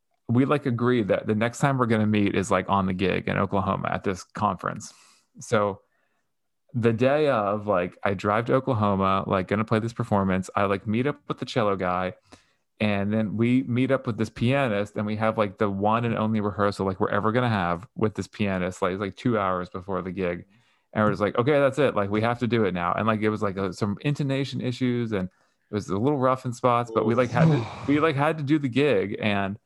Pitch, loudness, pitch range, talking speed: 110 Hz, -25 LUFS, 100-125 Hz, 240 wpm